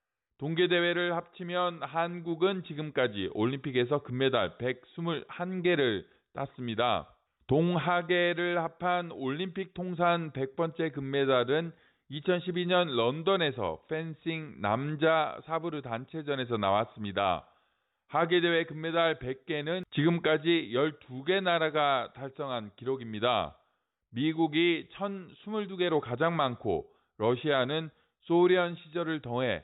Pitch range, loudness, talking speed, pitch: 135-175 Hz, -30 LUFS, 230 characters per minute, 160 Hz